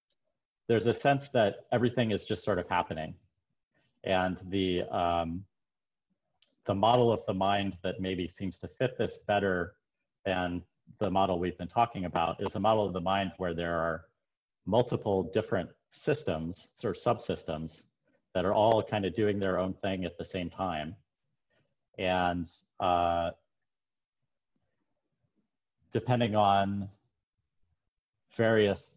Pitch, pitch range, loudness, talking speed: 95 Hz, 90-105 Hz, -31 LUFS, 135 wpm